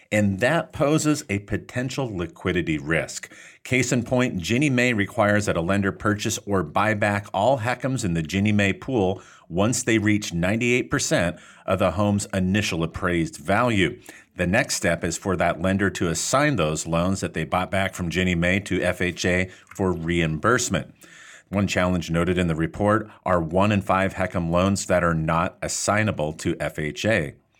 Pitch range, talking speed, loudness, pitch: 90-105 Hz, 165 wpm, -23 LUFS, 95 Hz